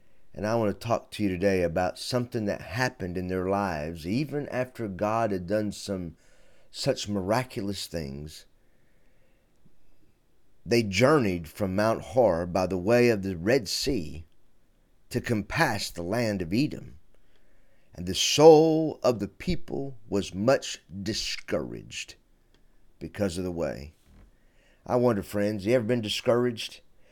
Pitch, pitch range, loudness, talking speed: 100 Hz, 95-120 Hz, -27 LUFS, 135 wpm